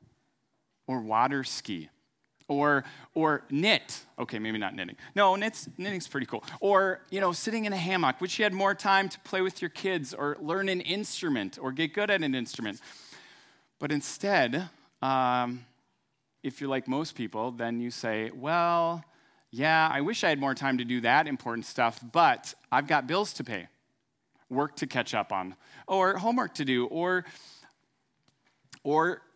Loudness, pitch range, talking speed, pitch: -29 LUFS, 130-190 Hz, 170 wpm, 155 Hz